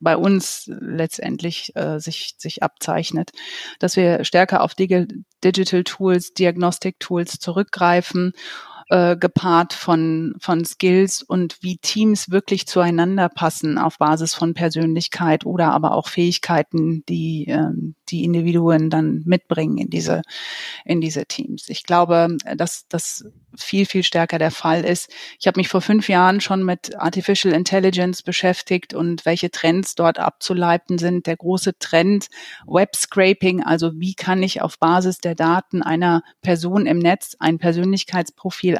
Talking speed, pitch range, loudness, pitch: 145 wpm, 165-185 Hz, -19 LUFS, 175 Hz